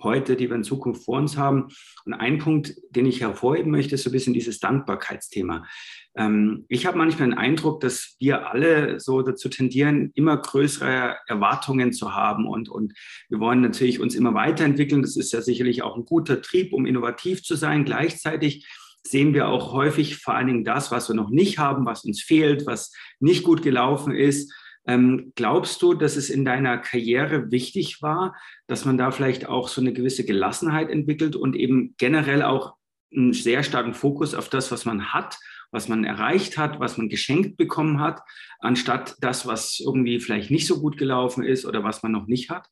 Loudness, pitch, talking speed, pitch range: -23 LUFS, 135 Hz, 190 wpm, 125-150 Hz